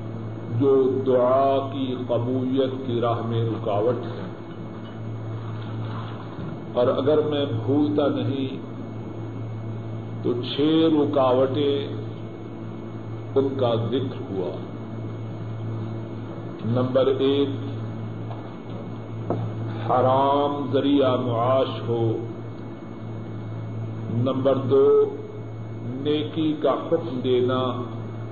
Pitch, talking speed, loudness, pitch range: 115 Hz, 70 wpm, -24 LUFS, 110-130 Hz